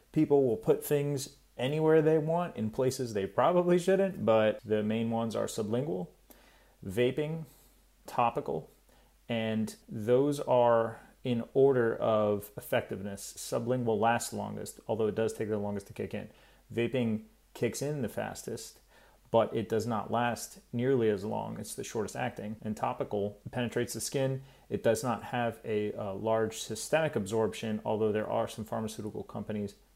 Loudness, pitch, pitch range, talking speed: -31 LUFS, 115 Hz, 110-130 Hz, 150 wpm